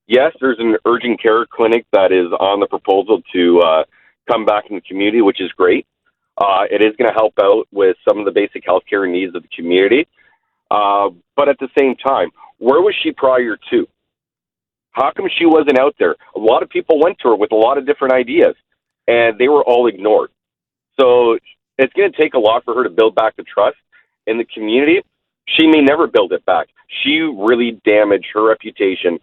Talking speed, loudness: 210 wpm, -14 LUFS